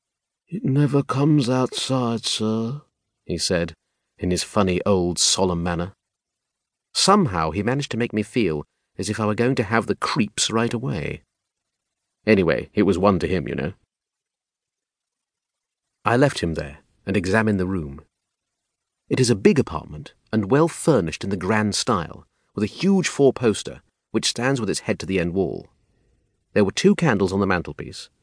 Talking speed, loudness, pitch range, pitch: 170 wpm, -21 LUFS, 90-120 Hz, 105 Hz